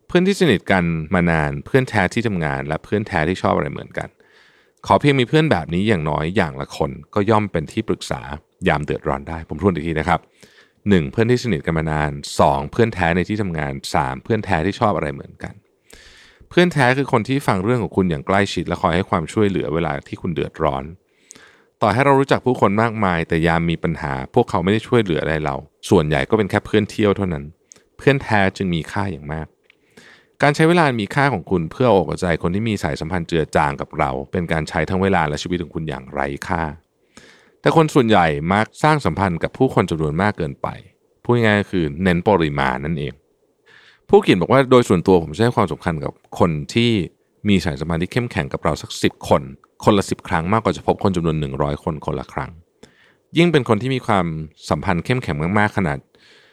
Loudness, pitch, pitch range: -19 LUFS, 95 Hz, 80-115 Hz